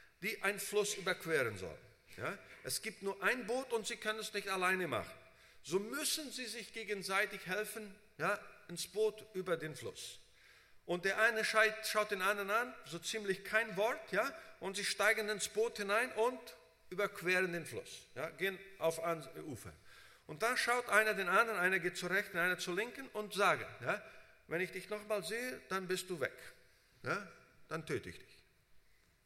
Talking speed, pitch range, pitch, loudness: 180 wpm, 185-220 Hz, 205 Hz, -37 LUFS